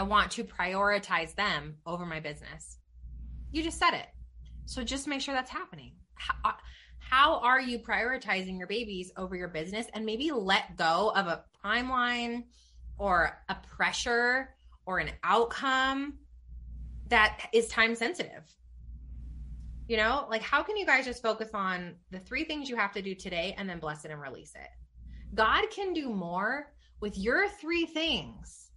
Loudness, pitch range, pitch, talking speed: -30 LUFS, 165-260 Hz, 210 Hz, 165 wpm